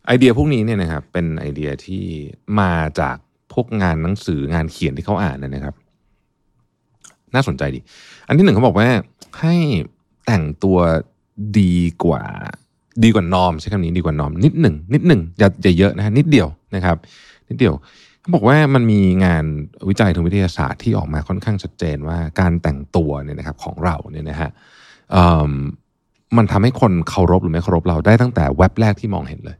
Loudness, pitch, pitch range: -17 LUFS, 90 Hz, 80-110 Hz